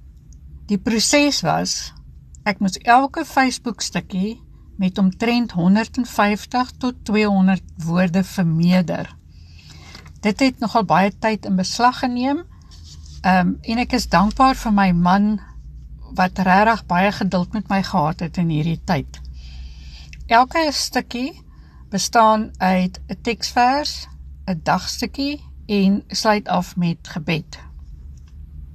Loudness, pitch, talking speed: -19 LUFS, 190 Hz, 115 wpm